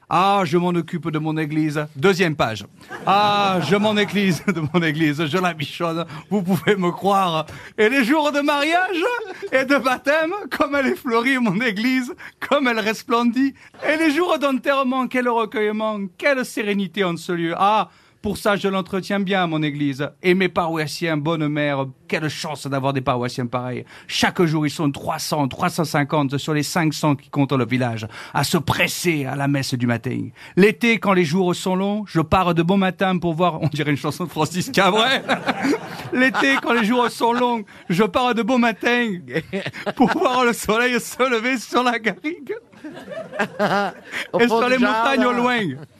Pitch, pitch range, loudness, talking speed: 195 Hz, 155-240 Hz, -20 LUFS, 180 wpm